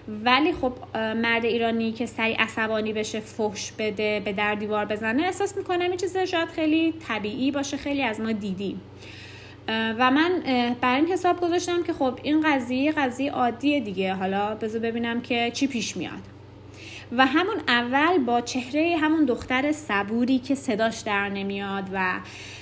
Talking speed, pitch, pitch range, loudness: 155 wpm, 235 Hz, 215-285 Hz, -24 LUFS